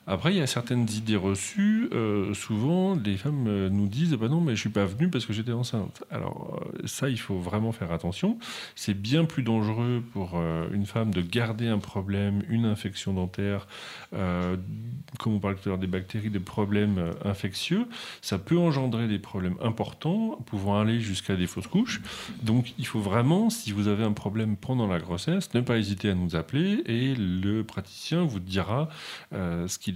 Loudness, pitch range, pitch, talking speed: -28 LUFS, 100-130 Hz, 110 Hz, 195 wpm